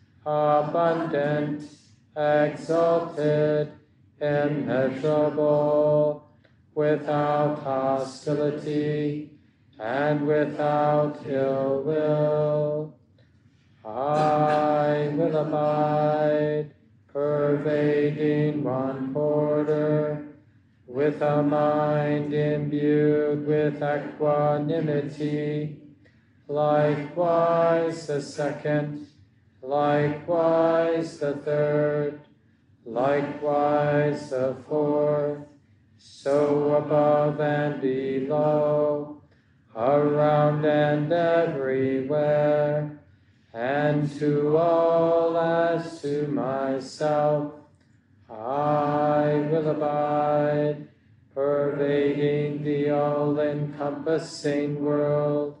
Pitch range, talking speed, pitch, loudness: 145-150 Hz, 55 wpm, 150 Hz, -24 LUFS